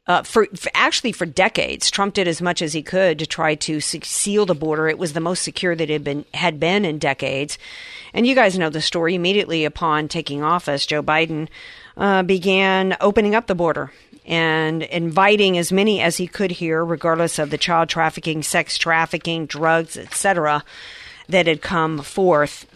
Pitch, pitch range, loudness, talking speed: 170 Hz, 155-190 Hz, -19 LUFS, 185 wpm